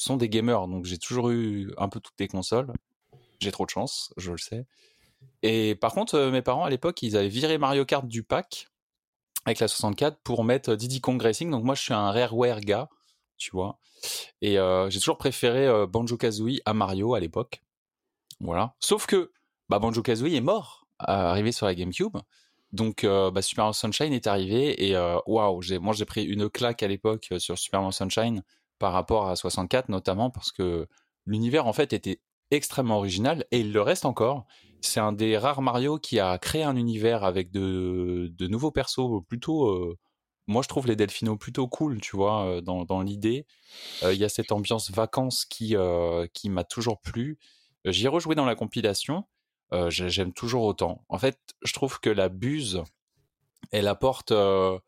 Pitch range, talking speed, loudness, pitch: 95-125 Hz, 195 wpm, -27 LUFS, 110 Hz